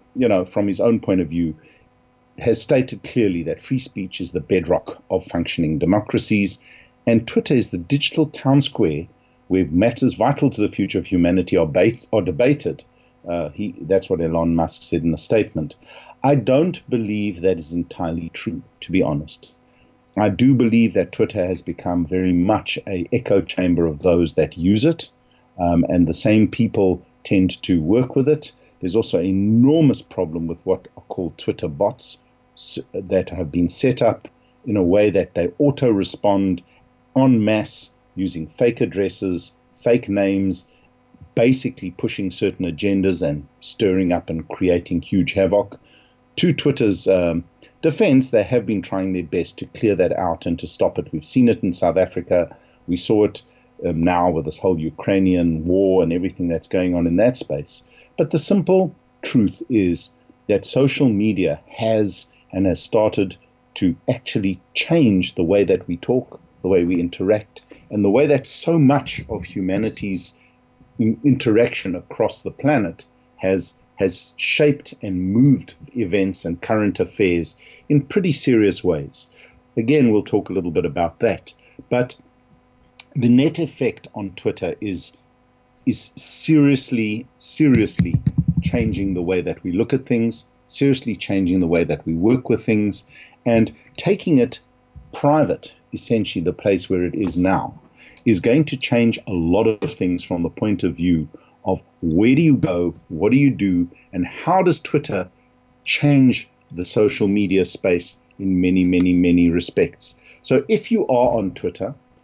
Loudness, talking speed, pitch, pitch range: -19 LUFS, 165 wpm, 100 Hz, 90-125 Hz